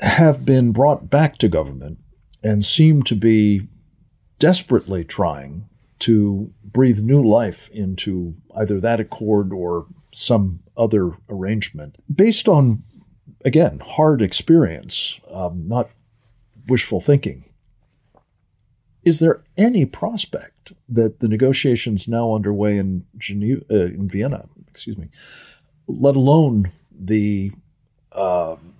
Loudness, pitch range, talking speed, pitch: -18 LUFS, 100-130 Hz, 110 wpm, 110 Hz